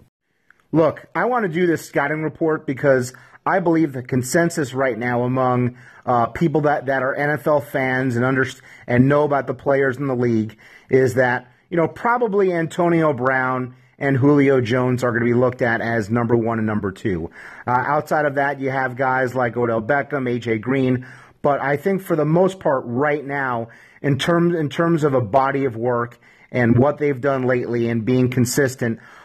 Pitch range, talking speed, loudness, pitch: 125-150 Hz, 190 wpm, -20 LUFS, 130 Hz